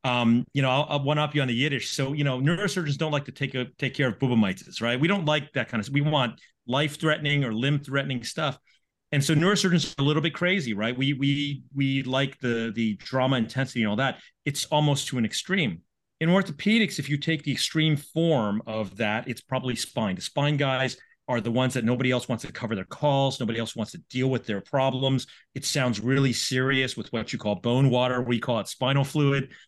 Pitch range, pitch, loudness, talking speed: 120-145 Hz, 135 Hz, -26 LUFS, 225 wpm